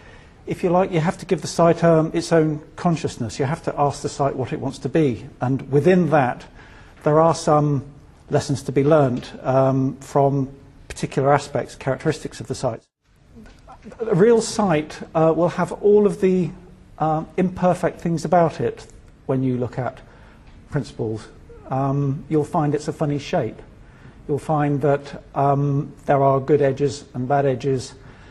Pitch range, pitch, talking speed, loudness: 135-165 Hz, 145 Hz, 165 wpm, -21 LUFS